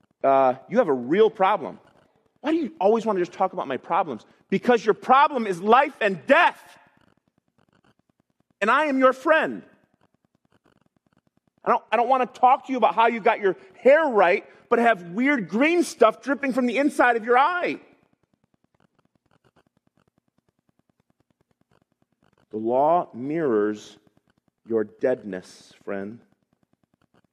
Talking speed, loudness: 140 wpm, -22 LUFS